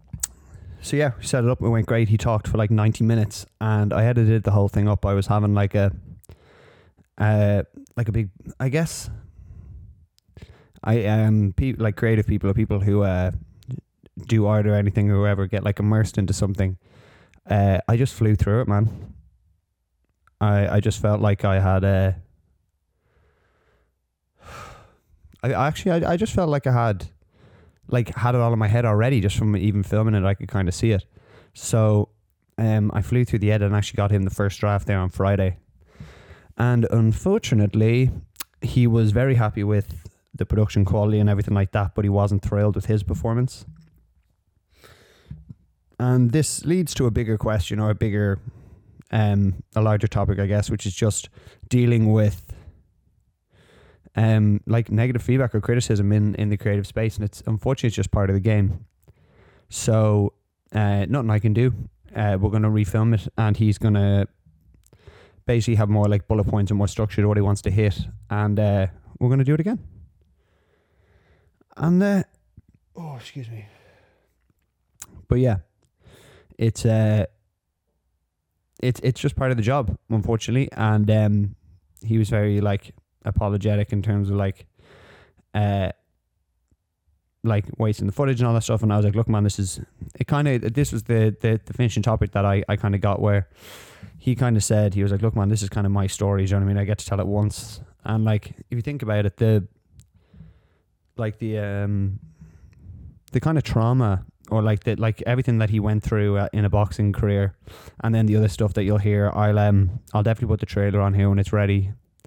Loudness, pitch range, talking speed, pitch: -22 LUFS, 100-110 Hz, 190 wpm, 105 Hz